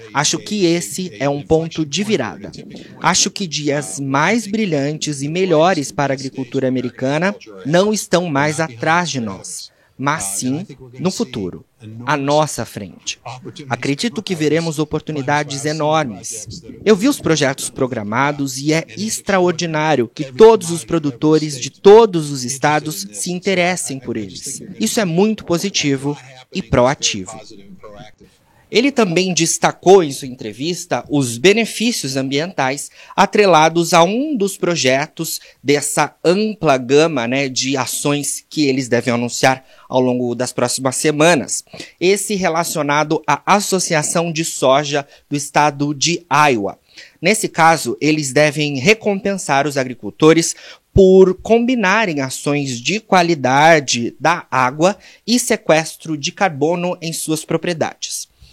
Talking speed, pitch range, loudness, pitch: 125 wpm, 135-180 Hz, -16 LUFS, 155 Hz